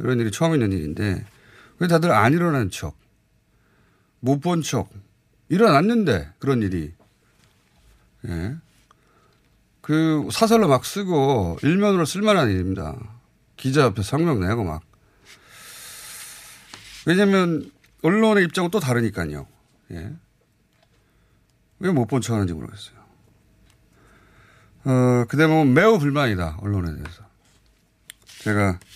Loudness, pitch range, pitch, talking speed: -21 LUFS, 100-155 Hz, 115 Hz, 225 characters per minute